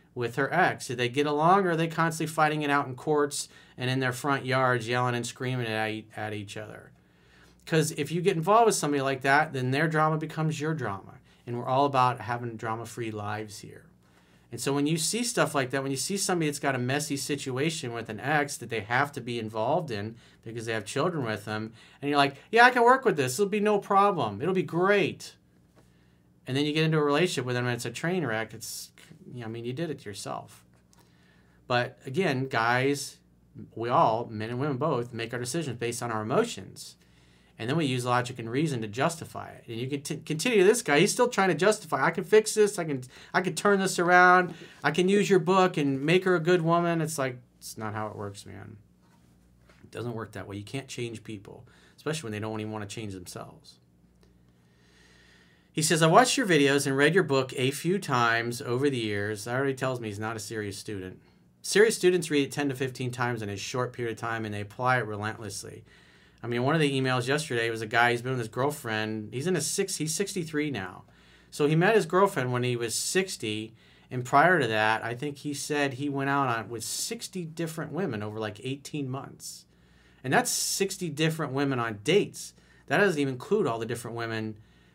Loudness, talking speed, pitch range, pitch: -27 LUFS, 225 wpm, 110-155 Hz, 130 Hz